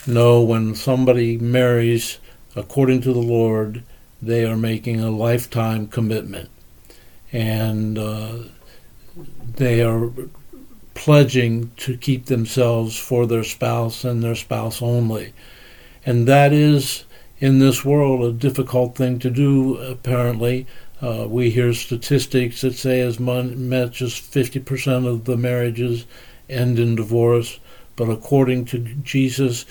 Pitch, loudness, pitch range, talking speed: 120 Hz, -19 LUFS, 115-130 Hz, 125 wpm